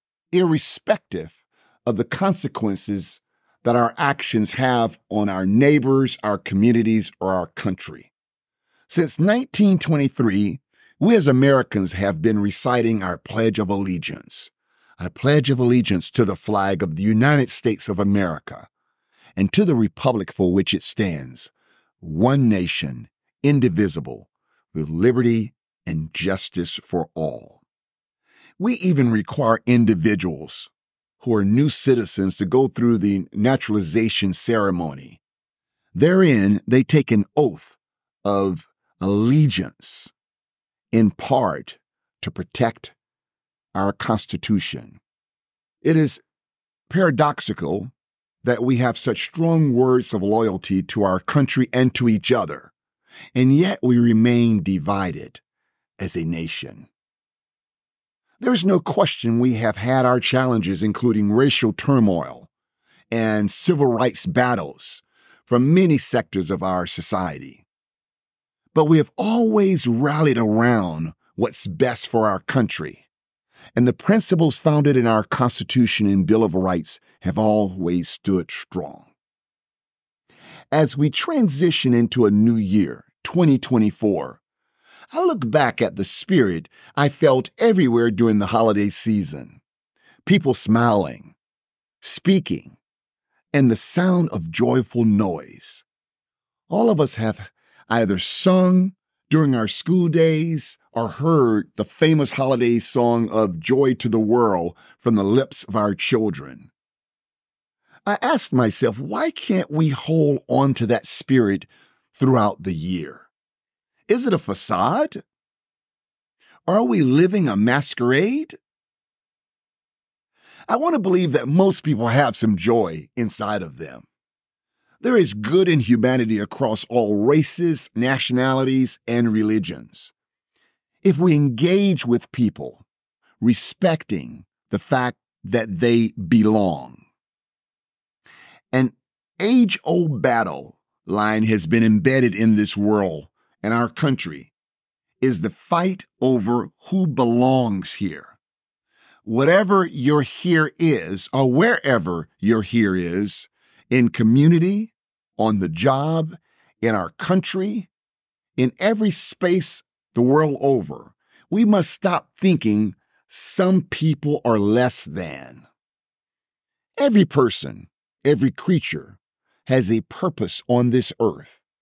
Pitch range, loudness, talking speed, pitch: 105-150 Hz, -20 LUFS, 120 wpm, 120 Hz